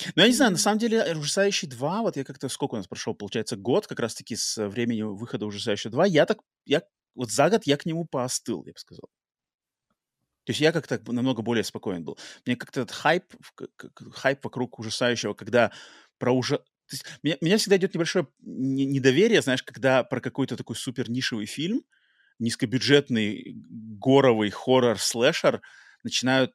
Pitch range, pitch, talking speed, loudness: 120-160 Hz, 130 Hz, 170 wpm, -25 LUFS